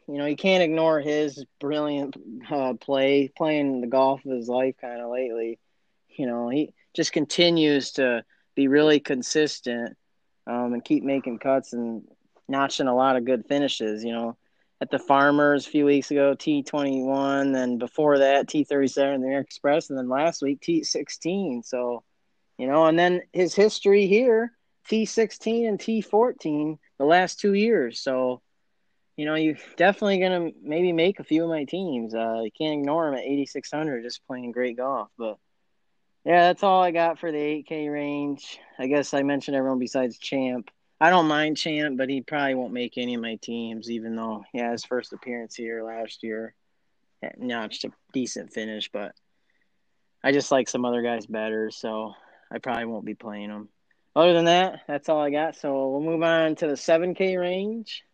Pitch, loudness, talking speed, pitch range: 140 Hz, -24 LUFS, 185 wpm, 125-160 Hz